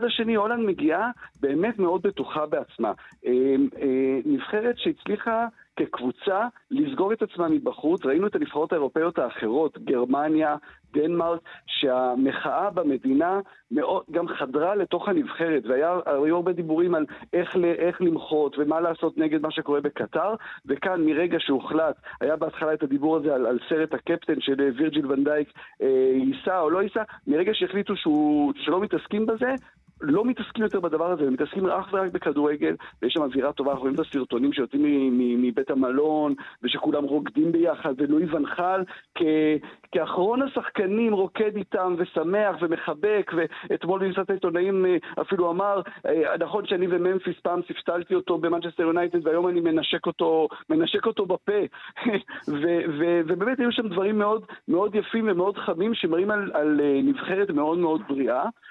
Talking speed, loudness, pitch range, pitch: 145 wpm, -25 LUFS, 150-205 Hz, 175 Hz